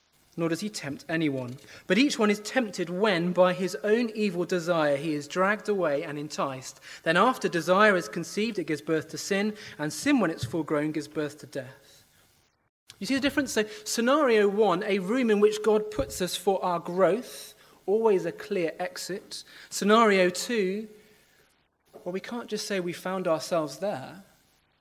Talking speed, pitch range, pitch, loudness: 180 wpm, 155-210 Hz, 185 Hz, -27 LUFS